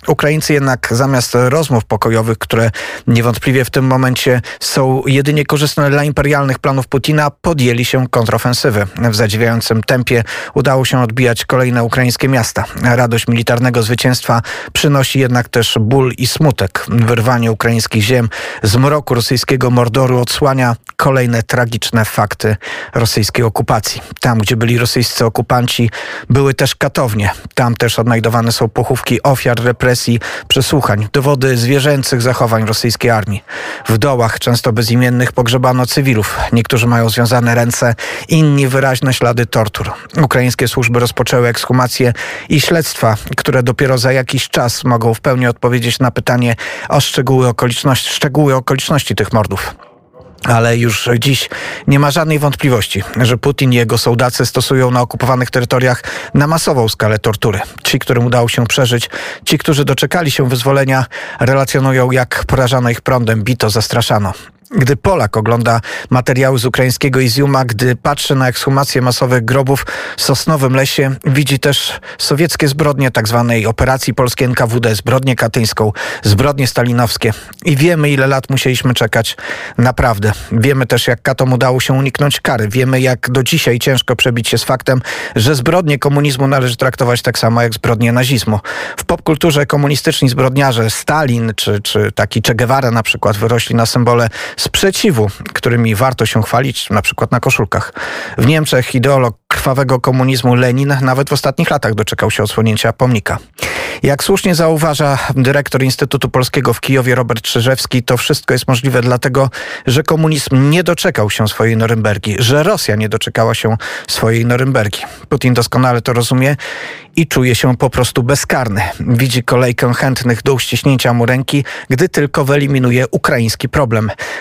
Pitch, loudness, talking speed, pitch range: 125 Hz, -12 LUFS, 145 wpm, 115-135 Hz